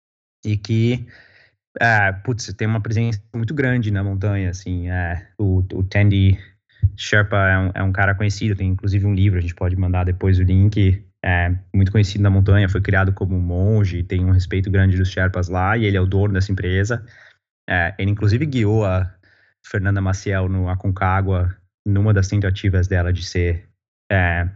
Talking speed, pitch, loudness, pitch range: 180 wpm, 95 Hz, -19 LUFS, 95-105 Hz